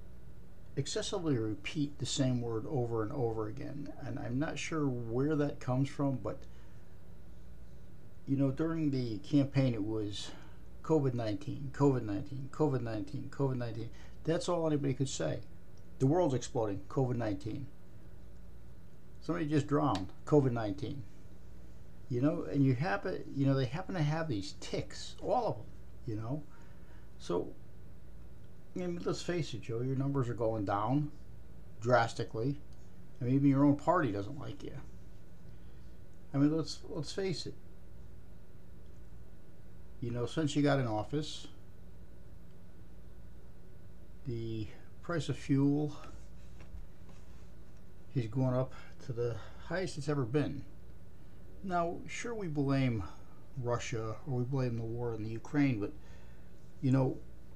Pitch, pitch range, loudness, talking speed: 130 Hz, 105-145 Hz, -35 LUFS, 130 wpm